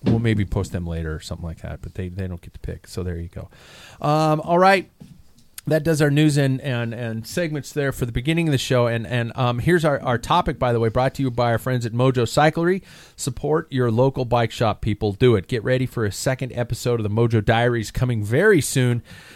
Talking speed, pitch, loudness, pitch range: 240 wpm, 125 Hz, -21 LUFS, 110-140 Hz